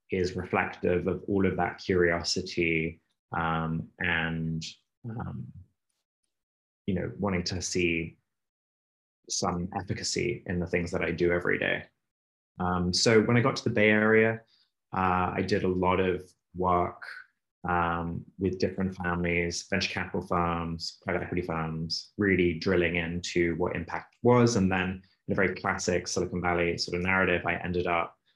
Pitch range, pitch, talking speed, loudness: 85-95 Hz, 90 Hz, 150 wpm, -28 LUFS